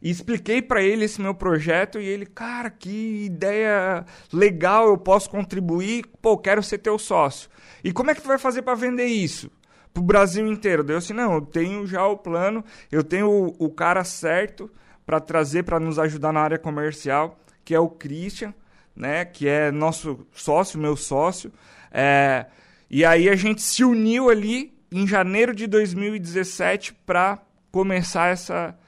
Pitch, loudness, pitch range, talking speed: 190 Hz, -22 LUFS, 165-215 Hz, 175 wpm